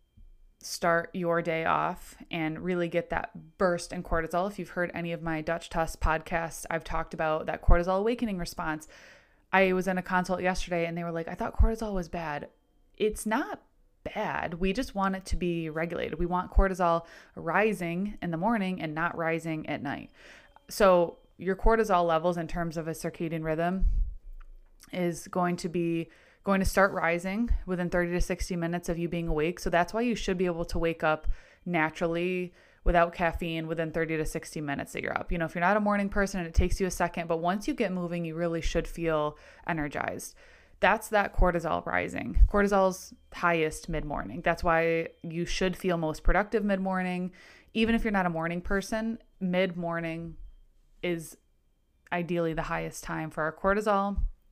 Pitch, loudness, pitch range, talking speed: 175 Hz, -30 LUFS, 165-190 Hz, 185 wpm